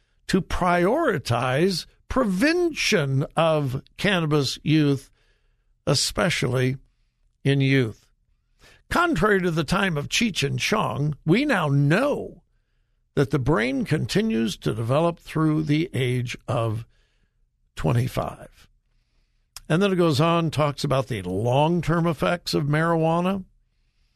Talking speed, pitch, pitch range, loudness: 110 wpm, 155 Hz, 135-175 Hz, -23 LUFS